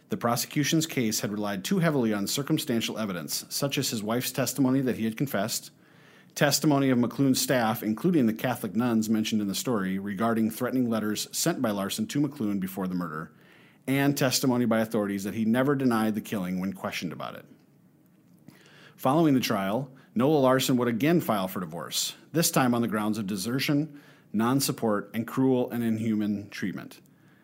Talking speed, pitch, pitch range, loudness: 175 wpm, 120 Hz, 110-140 Hz, -27 LUFS